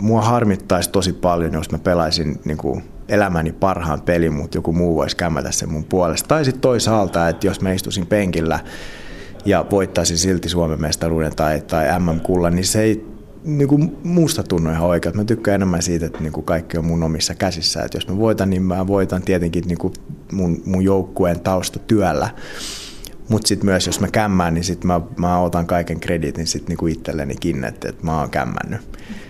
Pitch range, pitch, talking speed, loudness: 85-100 Hz, 90 Hz, 185 wpm, -19 LUFS